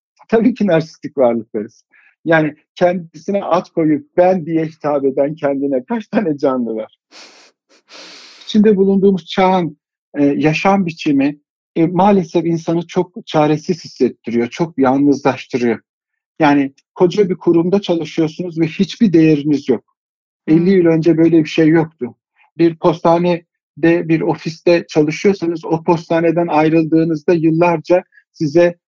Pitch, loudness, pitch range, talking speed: 165 Hz, -15 LUFS, 150-185 Hz, 120 wpm